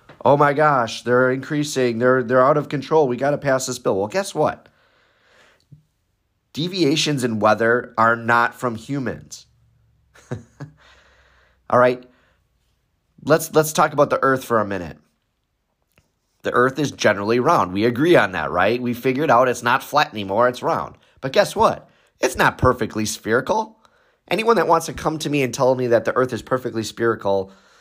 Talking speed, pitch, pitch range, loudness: 170 wpm, 125 Hz, 115-150 Hz, -19 LUFS